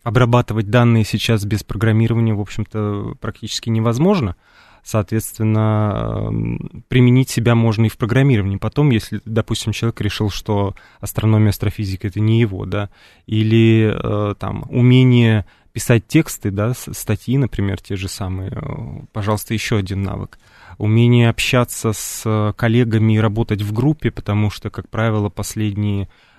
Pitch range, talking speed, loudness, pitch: 105-120 Hz, 125 wpm, -18 LUFS, 110 Hz